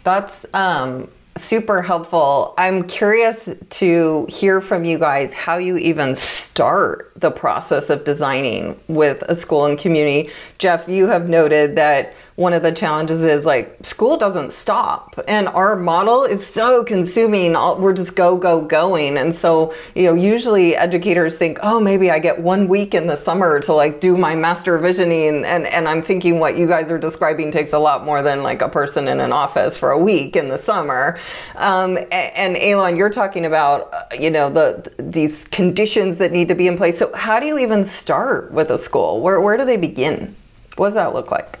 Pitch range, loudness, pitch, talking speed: 160-195 Hz, -16 LUFS, 175 Hz, 195 wpm